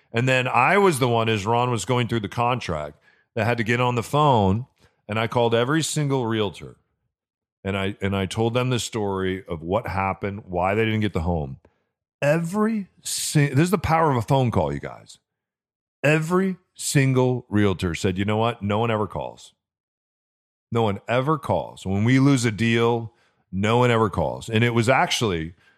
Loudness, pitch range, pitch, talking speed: -22 LUFS, 100-130 Hz, 115 Hz, 190 wpm